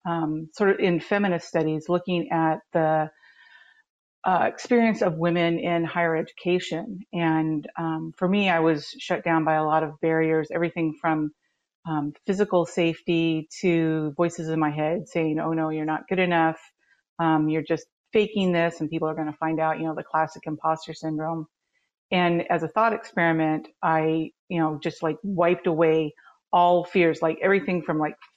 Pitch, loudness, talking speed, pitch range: 165 Hz, -24 LUFS, 175 wpm, 160-180 Hz